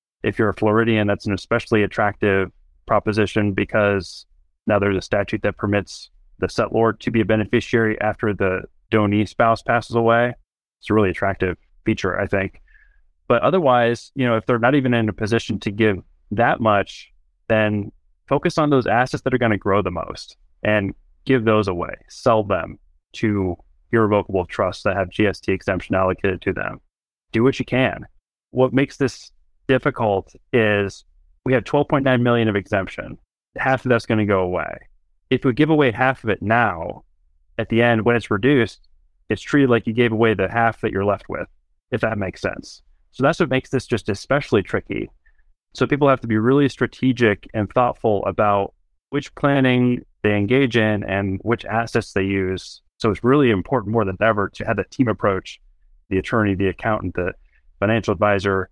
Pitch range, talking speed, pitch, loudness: 95-120 Hz, 180 wpm, 105 Hz, -20 LUFS